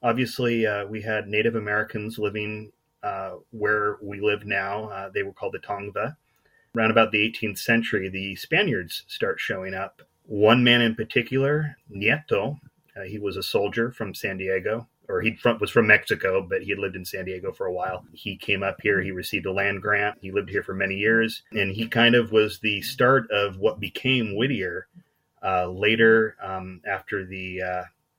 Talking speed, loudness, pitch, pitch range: 185 wpm, -24 LUFS, 110 Hz, 100-115 Hz